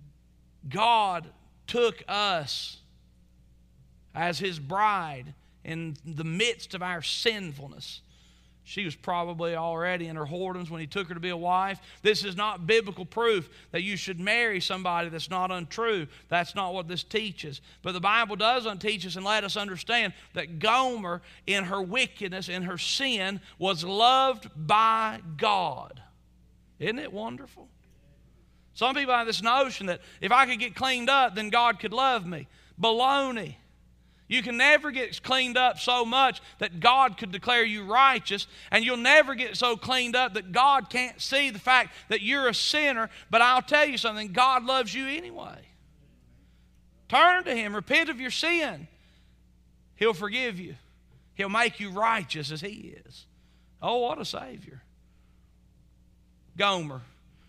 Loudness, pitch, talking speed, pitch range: -26 LUFS, 200 Hz, 155 wpm, 165-240 Hz